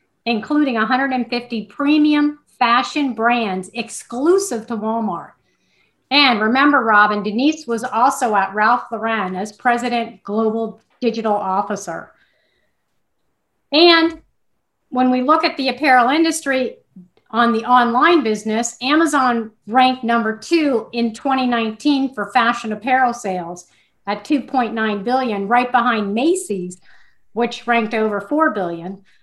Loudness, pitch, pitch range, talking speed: -17 LUFS, 235 Hz, 215-265 Hz, 115 wpm